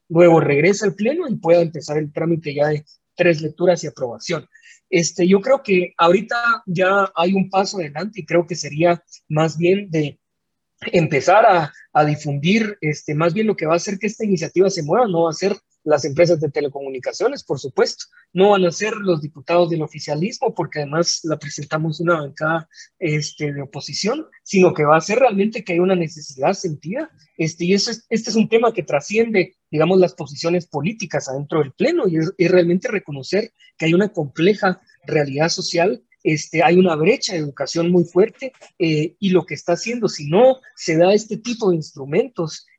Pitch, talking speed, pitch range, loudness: 175 Hz, 190 wpm, 155-195 Hz, -19 LUFS